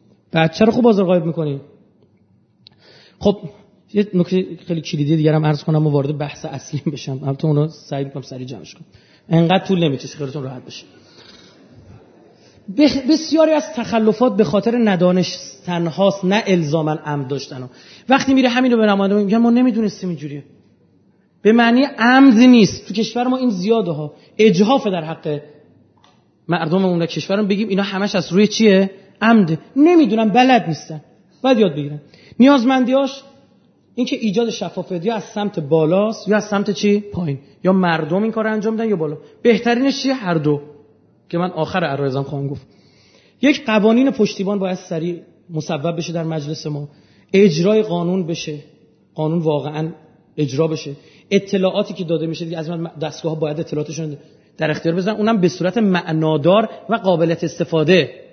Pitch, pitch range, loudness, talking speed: 180 Hz, 155-220 Hz, -17 LUFS, 155 wpm